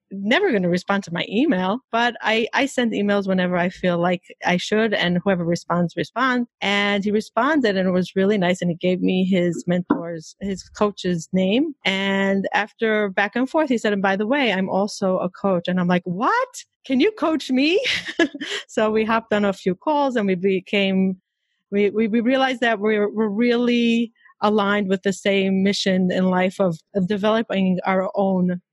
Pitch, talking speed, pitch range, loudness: 200 Hz, 190 wpm, 185-230 Hz, -21 LUFS